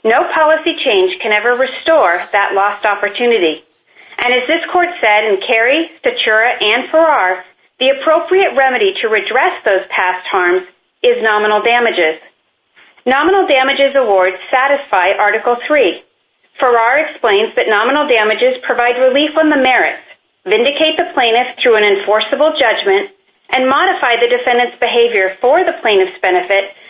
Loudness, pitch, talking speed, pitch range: -12 LUFS, 255 Hz, 140 wpm, 210-325 Hz